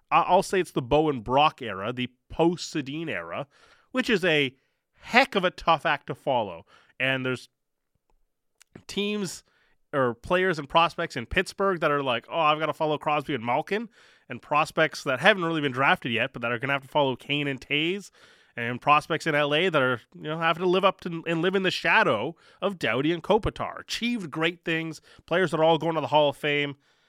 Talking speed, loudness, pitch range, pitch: 205 wpm, -25 LUFS, 140-180 Hz, 160 Hz